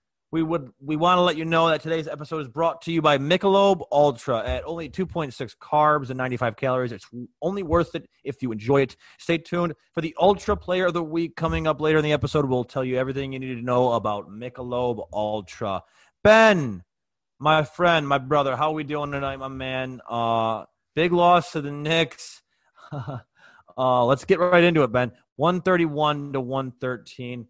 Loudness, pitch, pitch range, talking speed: -23 LUFS, 150 Hz, 130-165 Hz, 190 wpm